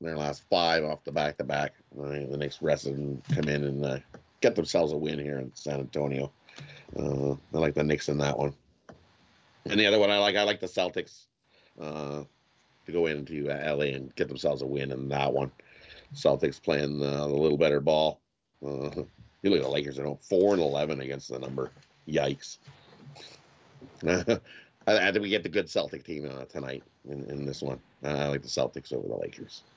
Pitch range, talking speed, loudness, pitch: 70-75 Hz, 195 wpm, -29 LUFS, 70 Hz